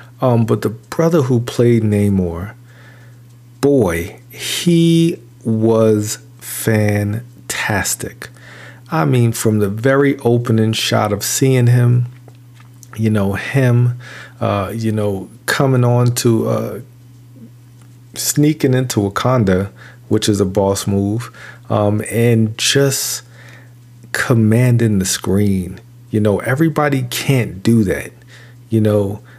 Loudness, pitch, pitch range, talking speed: -16 LUFS, 120 Hz, 110-125 Hz, 110 wpm